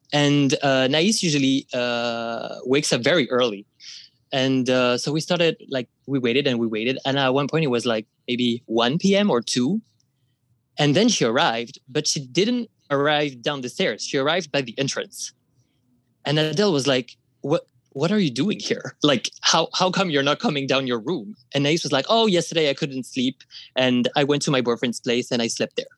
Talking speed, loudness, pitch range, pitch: 205 wpm, -22 LUFS, 125-155 Hz, 135 Hz